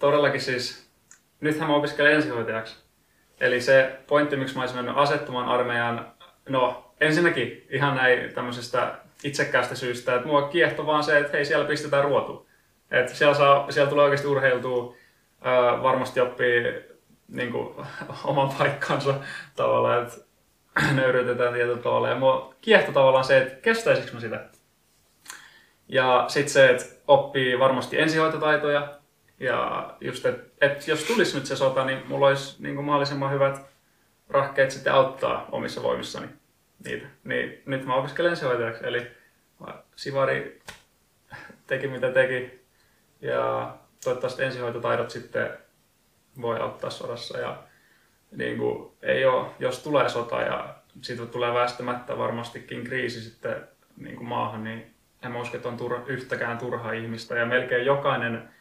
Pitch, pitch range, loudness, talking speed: 135 Hz, 125-145 Hz, -24 LUFS, 135 wpm